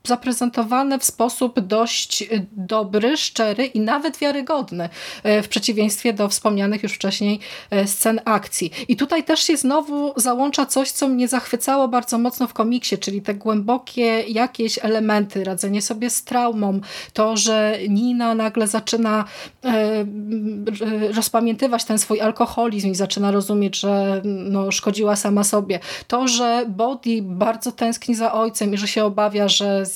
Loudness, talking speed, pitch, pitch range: -20 LUFS, 140 wpm, 225 Hz, 205-245 Hz